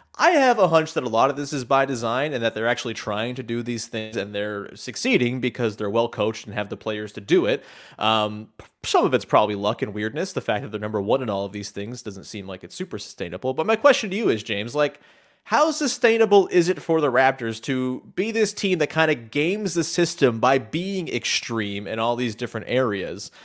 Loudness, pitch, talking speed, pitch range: -23 LUFS, 125 Hz, 235 wpm, 105-160 Hz